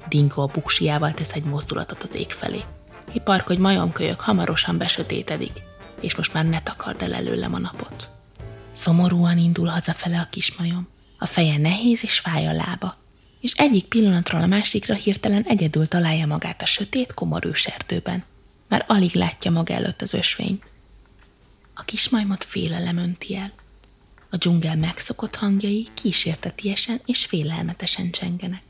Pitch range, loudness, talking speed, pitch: 160-200 Hz, -22 LUFS, 145 wpm, 175 Hz